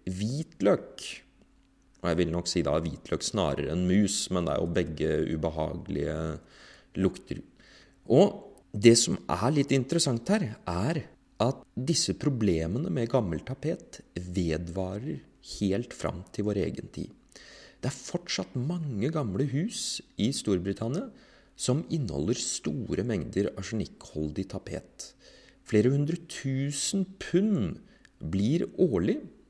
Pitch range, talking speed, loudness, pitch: 90-145 Hz, 120 wpm, -29 LUFS, 105 Hz